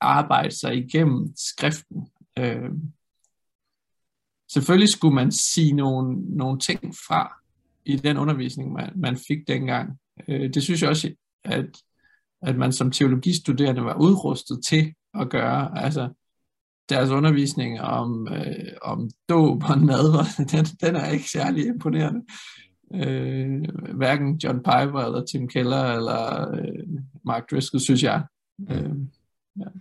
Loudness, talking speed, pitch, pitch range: -23 LUFS, 135 wpm, 145 Hz, 130-165 Hz